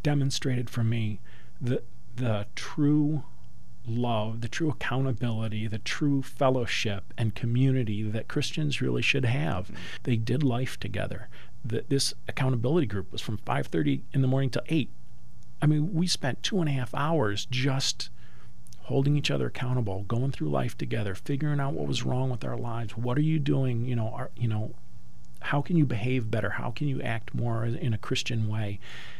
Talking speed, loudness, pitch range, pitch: 175 wpm, -29 LUFS, 110-140 Hz, 120 Hz